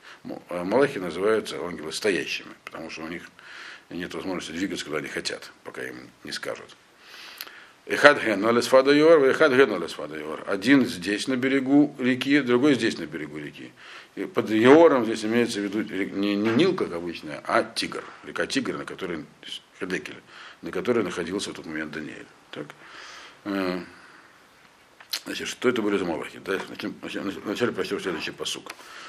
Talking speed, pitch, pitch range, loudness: 130 wpm, 115 Hz, 95-135 Hz, -24 LUFS